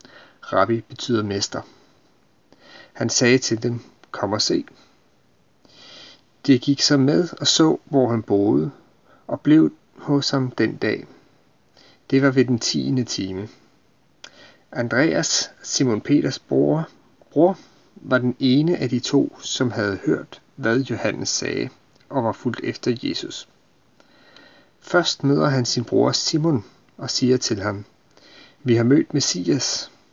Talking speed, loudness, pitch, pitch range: 130 wpm, -21 LUFS, 125 Hz, 115-140 Hz